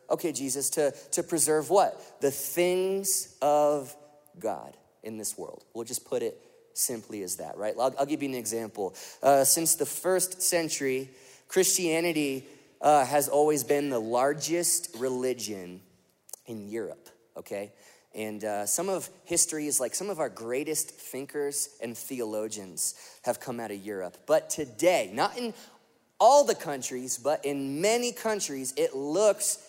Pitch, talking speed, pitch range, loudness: 145 Hz, 150 wpm, 125-175 Hz, -28 LUFS